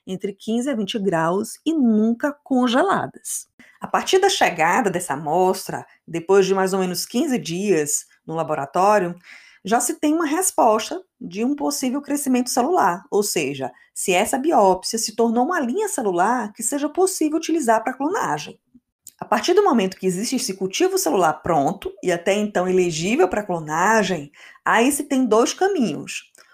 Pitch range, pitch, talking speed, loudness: 190-285 Hz, 230 Hz, 160 wpm, -20 LUFS